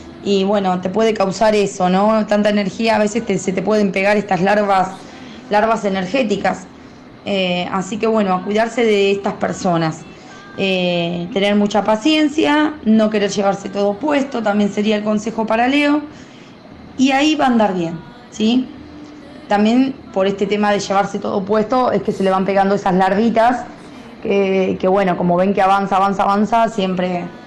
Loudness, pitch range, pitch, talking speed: -16 LUFS, 195-225 Hz, 205 Hz, 170 wpm